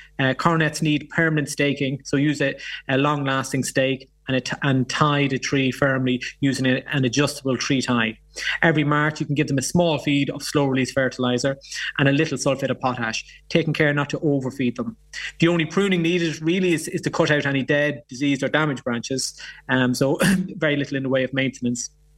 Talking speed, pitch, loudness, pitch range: 205 wpm, 140 Hz, -22 LUFS, 130-155 Hz